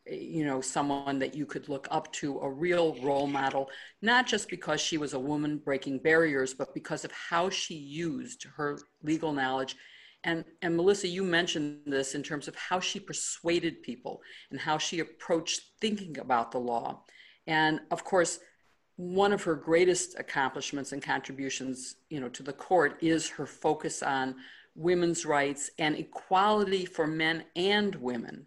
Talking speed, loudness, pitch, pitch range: 165 wpm, -30 LUFS, 160 Hz, 140-175 Hz